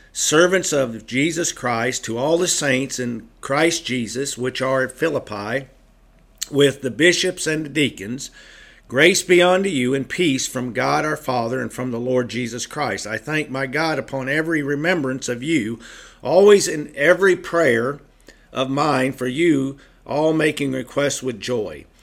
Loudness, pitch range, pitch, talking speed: -20 LUFS, 125-160 Hz, 135 Hz, 160 wpm